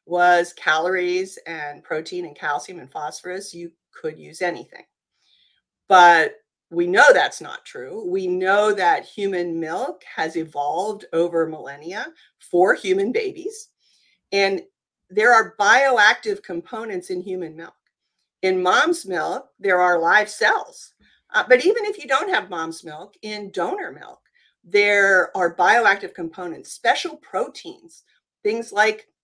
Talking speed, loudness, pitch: 135 wpm, -19 LUFS, 200 Hz